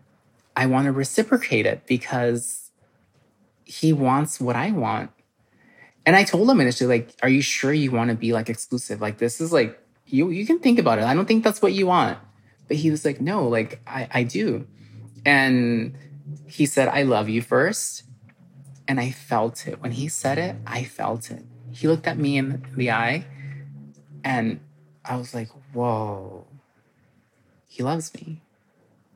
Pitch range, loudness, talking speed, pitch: 115-150 Hz, -22 LUFS, 175 wpm, 130 Hz